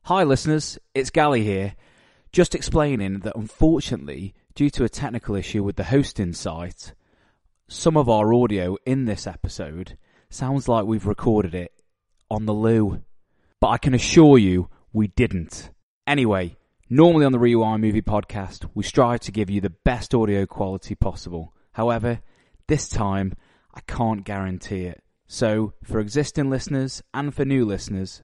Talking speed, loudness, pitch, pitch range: 155 wpm, -22 LUFS, 110 Hz, 95-130 Hz